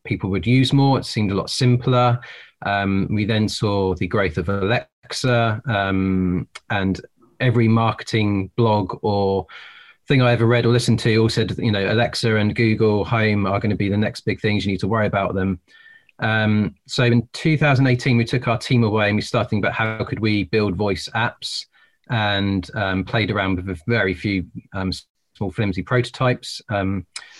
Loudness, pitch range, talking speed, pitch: -20 LUFS, 100-120 Hz, 185 wpm, 110 Hz